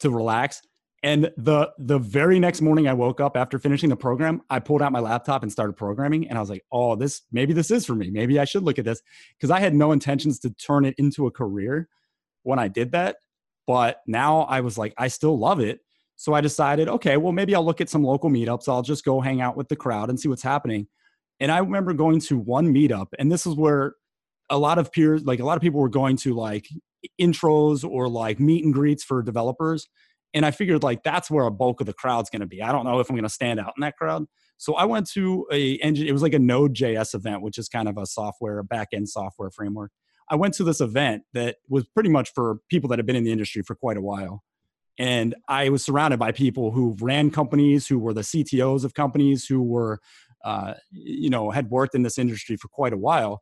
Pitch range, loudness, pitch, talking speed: 120-150 Hz, -23 LUFS, 135 Hz, 245 wpm